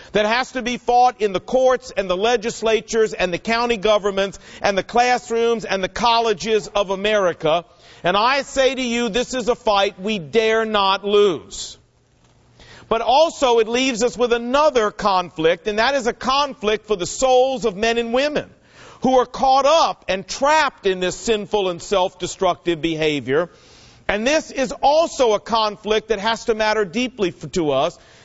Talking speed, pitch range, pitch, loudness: 175 wpm, 195-245 Hz, 220 Hz, -19 LUFS